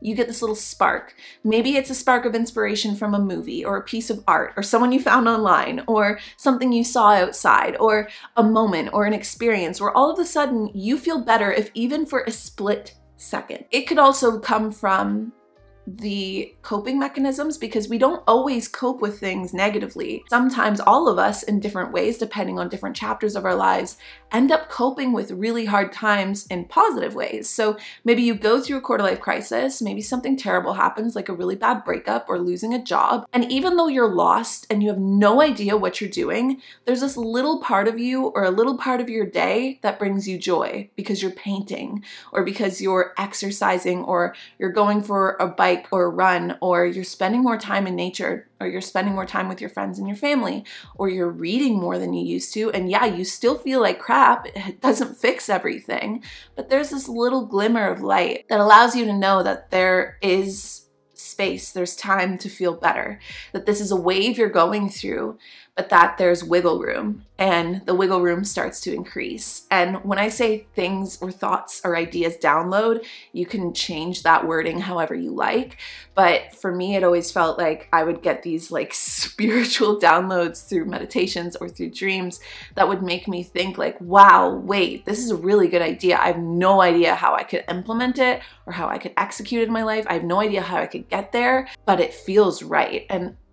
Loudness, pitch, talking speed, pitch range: -21 LUFS, 205 Hz, 205 wpm, 185-235 Hz